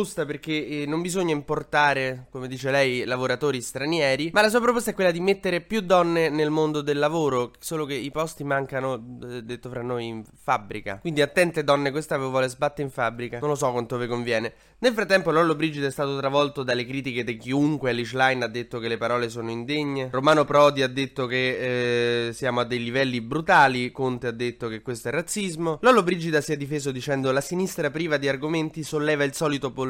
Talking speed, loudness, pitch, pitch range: 200 wpm, -24 LUFS, 140 Hz, 125-155 Hz